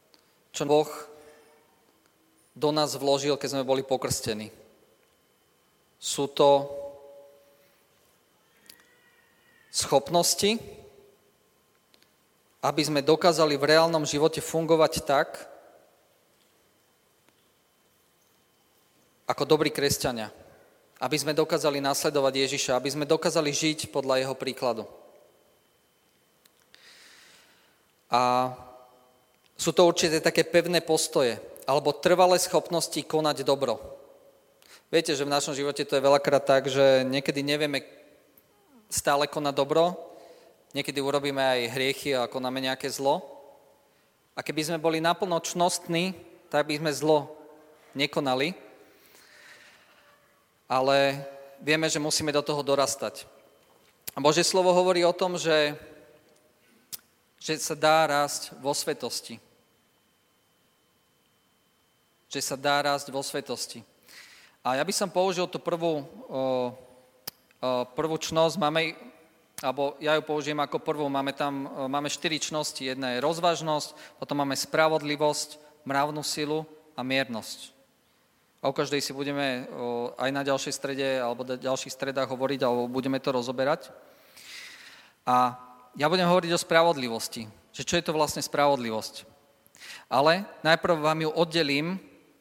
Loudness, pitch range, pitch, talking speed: -26 LUFS, 135-160 Hz, 150 Hz, 115 wpm